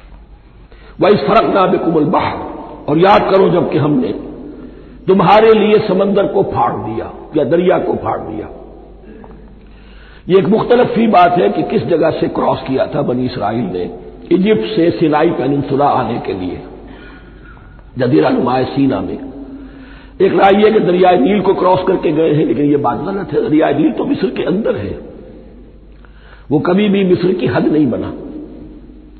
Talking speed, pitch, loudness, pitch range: 165 wpm, 180 Hz, -13 LUFS, 145-205 Hz